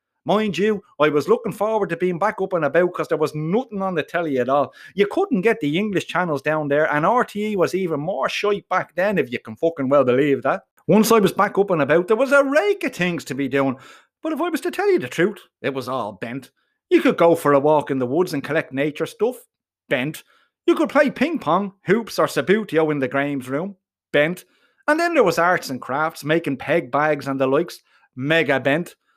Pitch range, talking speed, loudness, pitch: 145-215 Hz, 235 wpm, -20 LUFS, 170 Hz